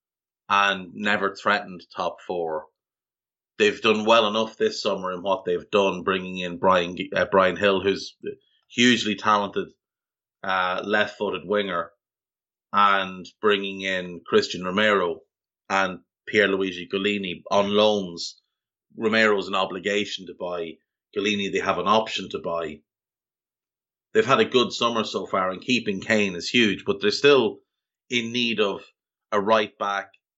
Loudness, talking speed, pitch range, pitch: -23 LUFS, 140 wpm, 95-105 Hz, 100 Hz